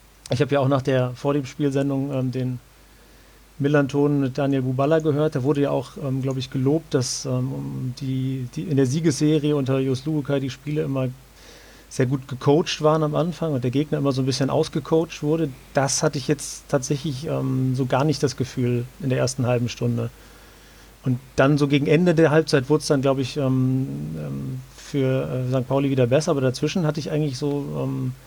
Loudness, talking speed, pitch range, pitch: -23 LUFS, 195 wpm, 130-150 Hz, 140 Hz